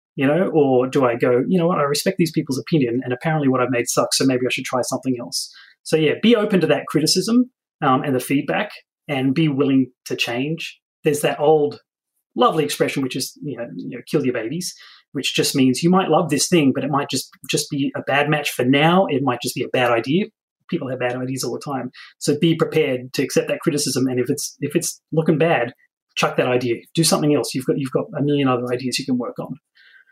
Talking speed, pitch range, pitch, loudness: 245 wpm, 130-160 Hz, 145 Hz, -20 LUFS